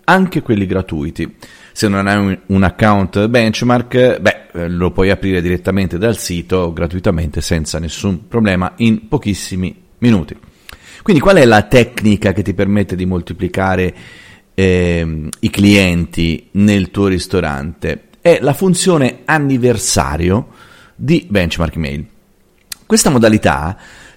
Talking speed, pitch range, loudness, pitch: 120 wpm, 90-115 Hz, -14 LUFS, 100 Hz